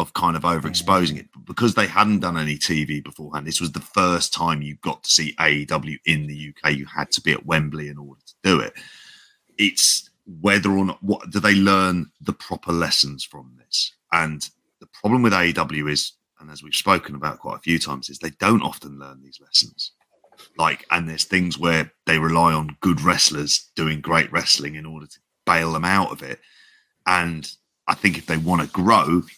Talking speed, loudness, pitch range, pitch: 205 wpm, -20 LUFS, 75-90 Hz, 80 Hz